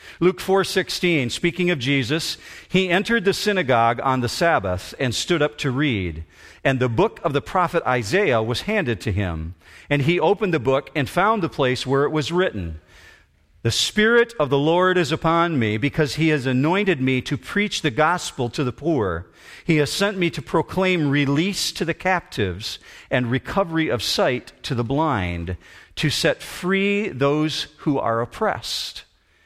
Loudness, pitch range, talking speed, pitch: -21 LUFS, 125-175 Hz, 175 wpm, 150 Hz